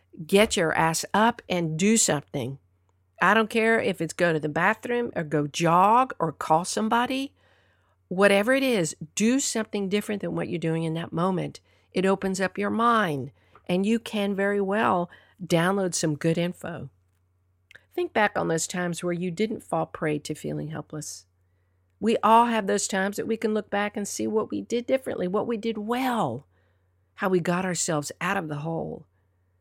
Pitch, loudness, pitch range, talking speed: 175 Hz, -25 LUFS, 150-210 Hz, 180 wpm